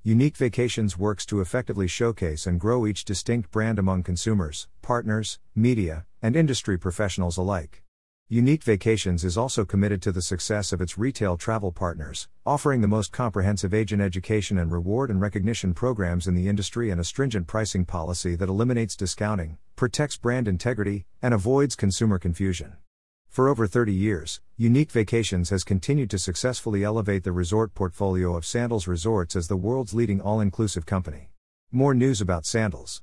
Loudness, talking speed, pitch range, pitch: -25 LUFS, 160 wpm, 90-115 Hz, 100 Hz